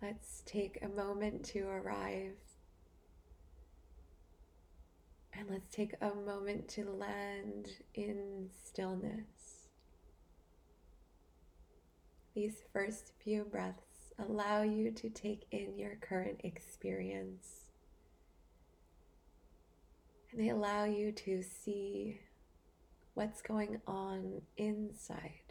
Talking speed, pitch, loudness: 85 wpm, 100 Hz, -42 LUFS